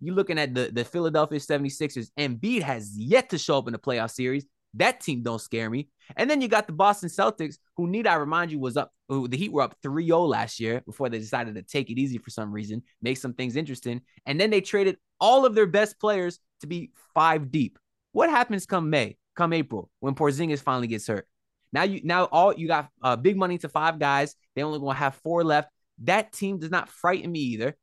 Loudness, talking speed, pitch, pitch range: -26 LUFS, 230 wpm, 150 Hz, 130-175 Hz